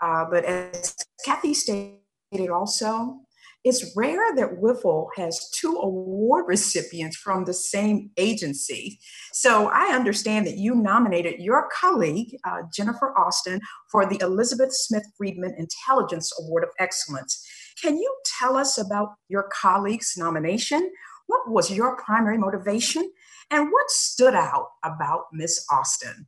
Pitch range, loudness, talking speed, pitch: 180-260 Hz, -23 LUFS, 130 wpm, 210 Hz